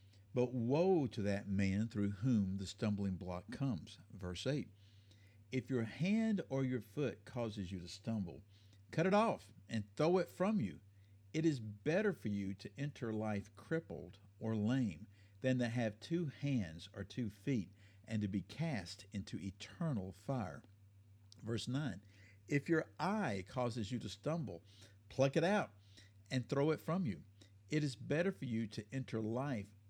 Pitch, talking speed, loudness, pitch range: 110 Hz, 165 wpm, -40 LUFS, 100-135 Hz